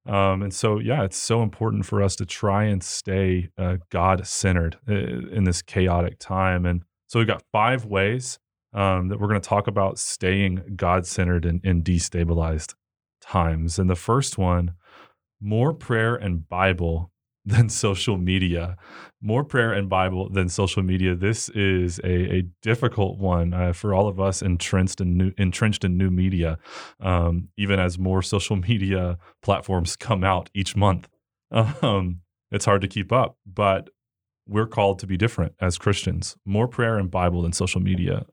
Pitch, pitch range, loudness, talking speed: 95 Hz, 90-105 Hz, -23 LUFS, 170 wpm